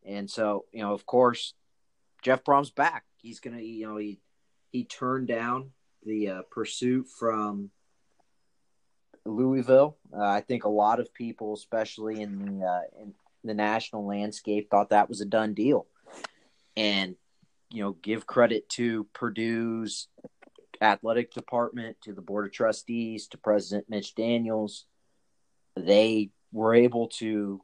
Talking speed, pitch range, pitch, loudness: 145 wpm, 105-120 Hz, 110 Hz, -28 LUFS